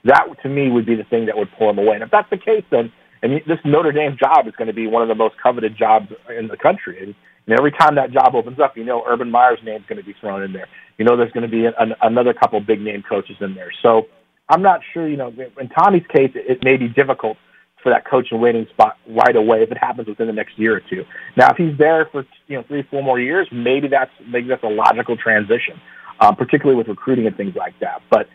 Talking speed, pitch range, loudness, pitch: 275 wpm, 110-140 Hz, -16 LUFS, 120 Hz